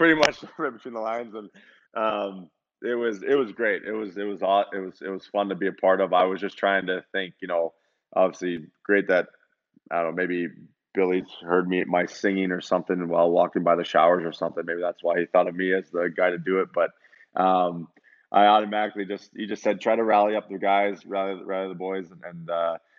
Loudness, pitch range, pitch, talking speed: -25 LUFS, 90-100 Hz, 95 Hz, 235 wpm